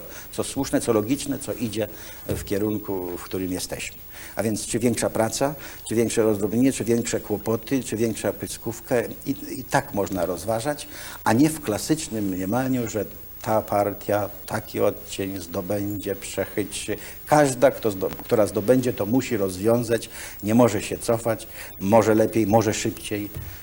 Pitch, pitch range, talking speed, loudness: 110 Hz, 100-115 Hz, 150 wpm, -24 LUFS